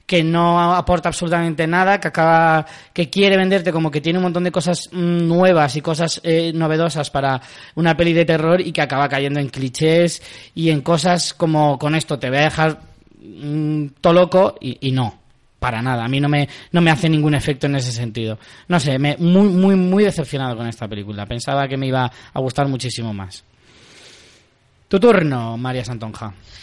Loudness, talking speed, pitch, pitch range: -17 LUFS, 190 wpm, 155 Hz, 130-170 Hz